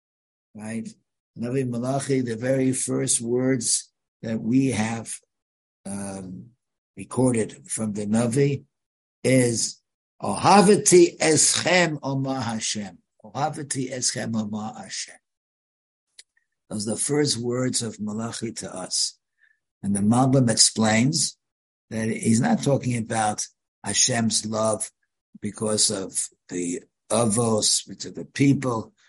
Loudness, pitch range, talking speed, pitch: -22 LUFS, 110-130 Hz, 105 wpm, 115 Hz